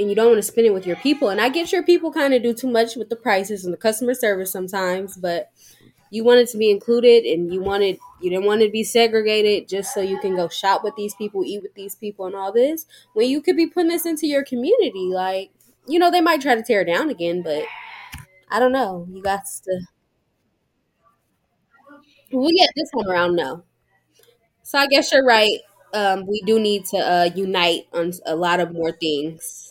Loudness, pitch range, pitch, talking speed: -19 LUFS, 185-260 Hz, 210 Hz, 230 wpm